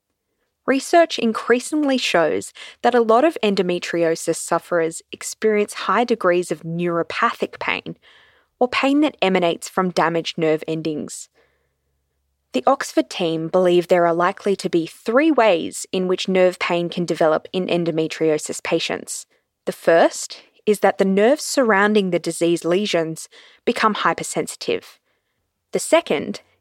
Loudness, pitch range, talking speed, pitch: -19 LUFS, 165-225 Hz, 130 wpm, 180 Hz